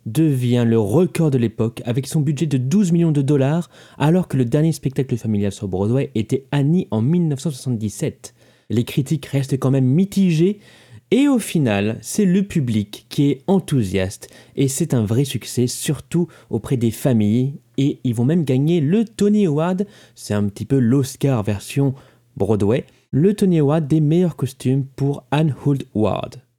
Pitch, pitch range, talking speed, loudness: 135 Hz, 120-160 Hz, 165 wpm, -19 LUFS